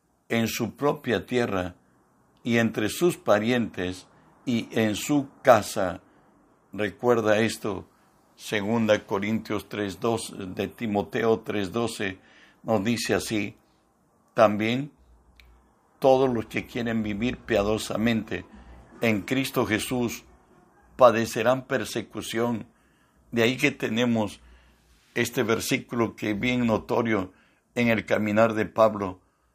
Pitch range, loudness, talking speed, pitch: 100-120 Hz, -26 LUFS, 100 wpm, 110 Hz